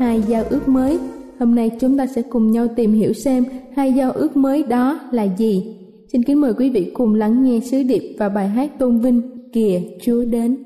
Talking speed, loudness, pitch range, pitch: 220 wpm, -18 LUFS, 225-265 Hz, 245 Hz